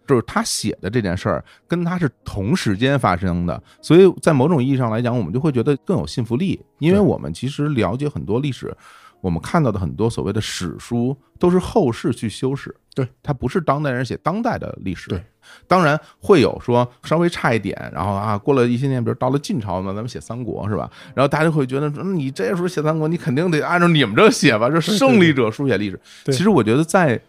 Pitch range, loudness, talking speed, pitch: 110-155 Hz, -19 LUFS, 345 characters per minute, 130 Hz